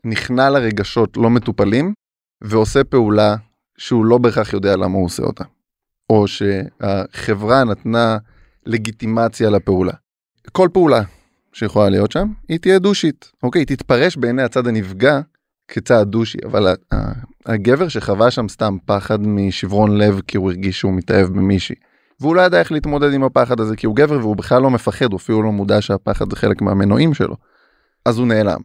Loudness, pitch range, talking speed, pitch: -16 LUFS, 100-125 Hz, 160 wpm, 110 Hz